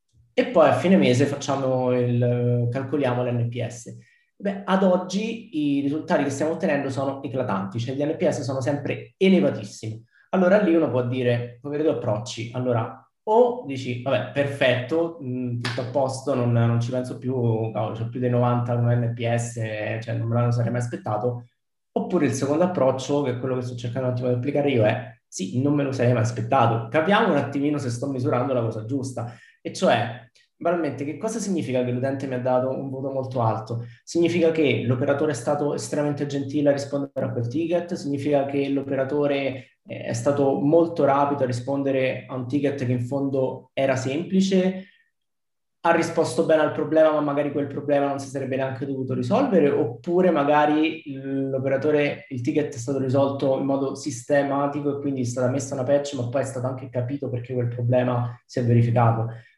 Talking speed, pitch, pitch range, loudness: 180 wpm, 135 Hz, 125-145 Hz, -23 LUFS